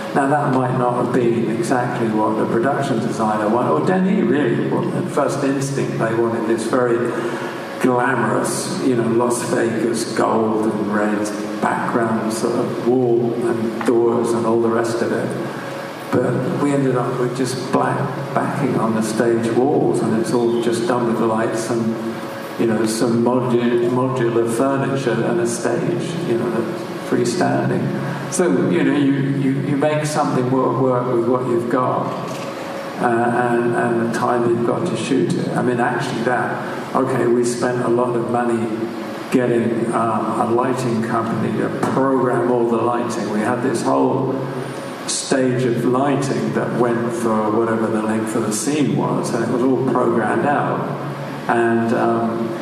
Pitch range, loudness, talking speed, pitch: 115-125 Hz, -19 LUFS, 165 wpm, 120 Hz